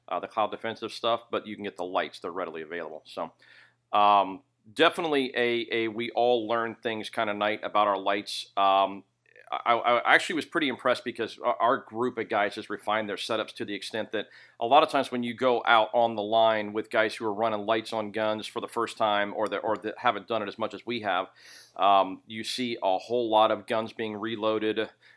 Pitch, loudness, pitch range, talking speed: 110 Hz, -27 LUFS, 105-115 Hz, 225 wpm